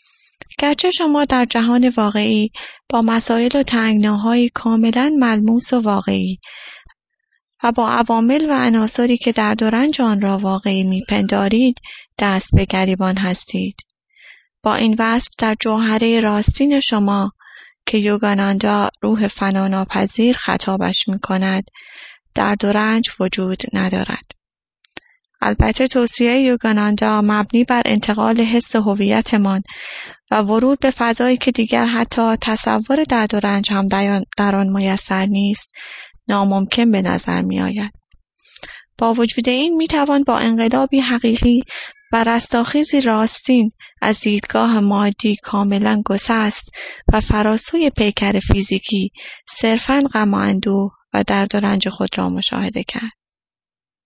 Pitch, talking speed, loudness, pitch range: 220 Hz, 120 wpm, -17 LUFS, 200-240 Hz